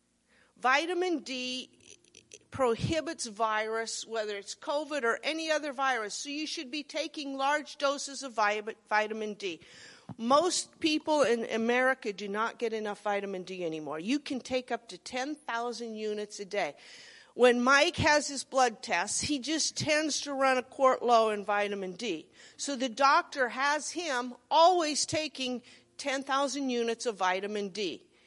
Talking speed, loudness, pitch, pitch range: 150 wpm, -30 LUFS, 255 Hz, 225-290 Hz